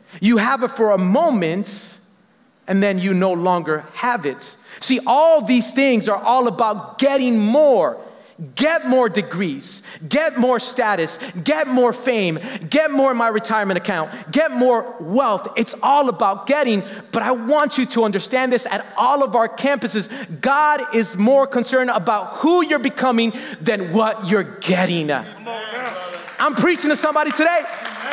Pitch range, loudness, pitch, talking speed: 200-270 Hz, -18 LUFS, 235 Hz, 155 wpm